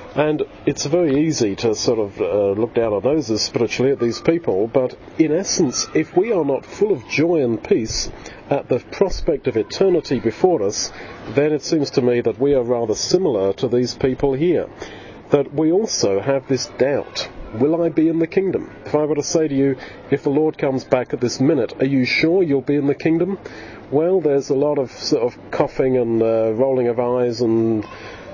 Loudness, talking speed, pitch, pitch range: -19 LUFS, 210 wpm, 140 Hz, 125-160 Hz